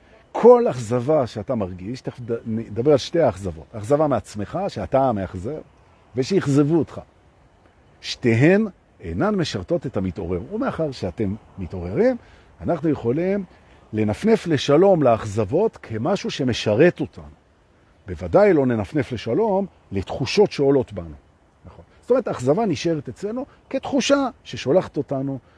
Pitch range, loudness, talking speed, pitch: 105-175 Hz, -21 LUFS, 110 wpm, 135 Hz